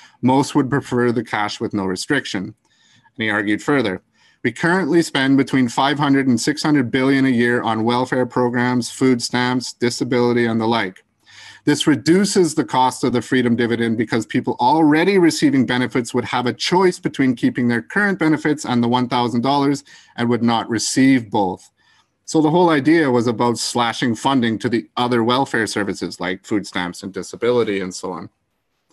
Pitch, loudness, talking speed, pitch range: 125 Hz, -18 LUFS, 170 wpm, 115-140 Hz